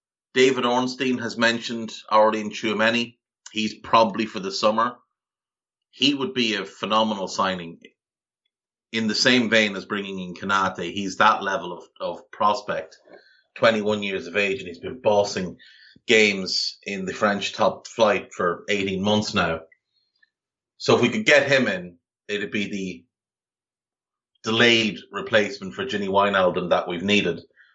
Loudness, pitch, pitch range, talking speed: -22 LUFS, 110 Hz, 100-120 Hz, 150 wpm